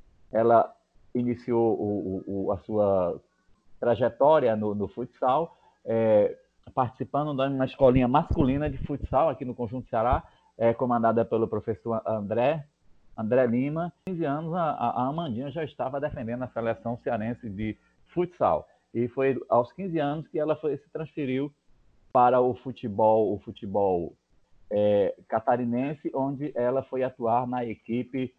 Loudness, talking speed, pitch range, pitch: -27 LUFS, 140 wpm, 110-135 Hz, 120 Hz